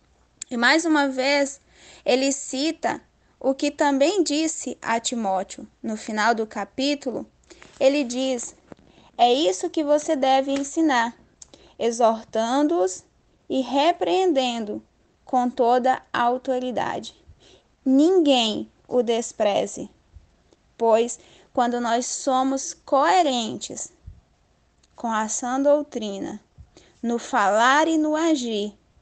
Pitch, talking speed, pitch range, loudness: 260 Hz, 95 wpm, 235-290 Hz, -22 LUFS